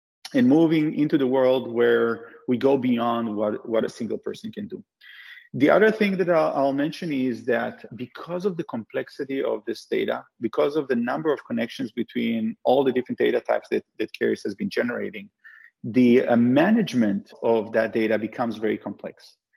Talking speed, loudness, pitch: 180 wpm, -23 LUFS, 140 Hz